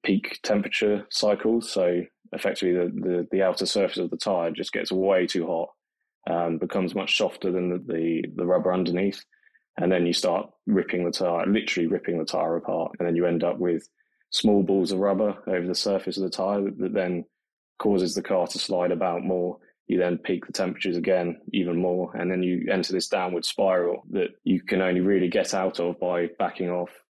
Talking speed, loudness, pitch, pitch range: 200 wpm, -25 LUFS, 90 Hz, 90-95 Hz